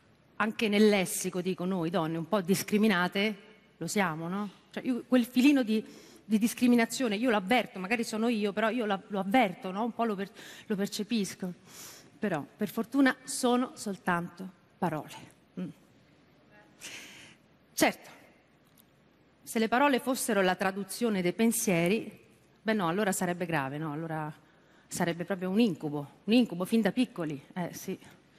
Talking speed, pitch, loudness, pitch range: 150 wpm, 200 Hz, -30 LUFS, 180-230 Hz